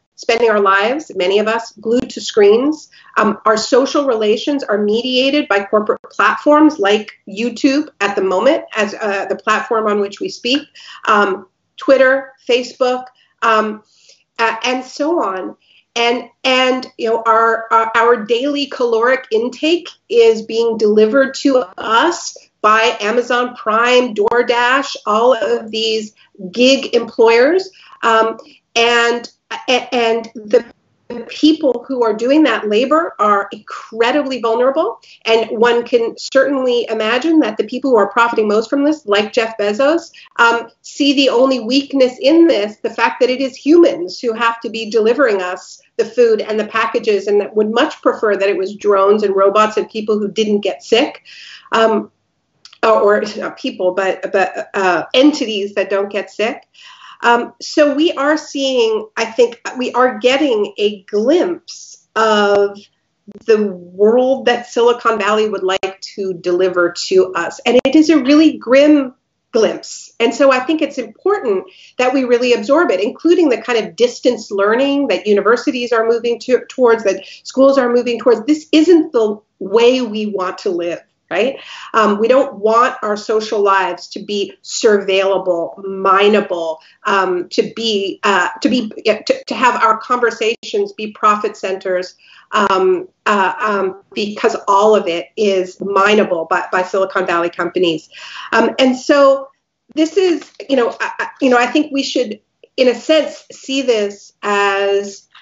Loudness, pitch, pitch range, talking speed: -14 LUFS, 230 Hz, 210-270 Hz, 155 wpm